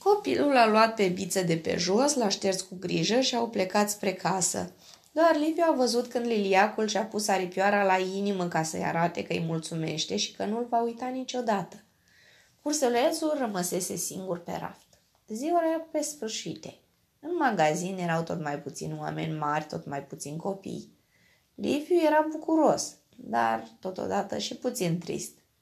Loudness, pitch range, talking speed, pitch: -28 LUFS, 170-255 Hz, 160 wpm, 200 Hz